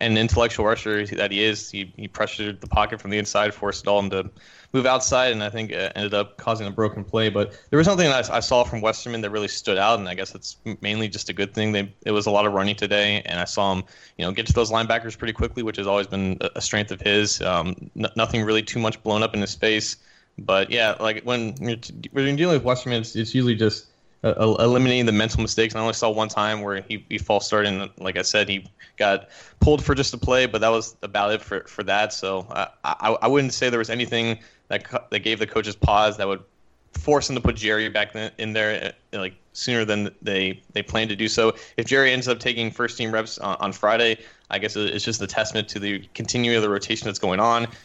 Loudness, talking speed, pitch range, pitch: -22 LUFS, 255 wpm, 105-115 Hz, 110 Hz